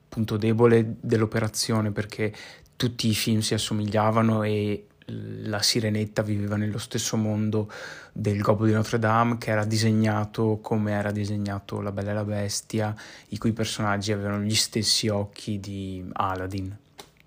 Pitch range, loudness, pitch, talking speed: 105-110 Hz, -25 LUFS, 110 Hz, 140 wpm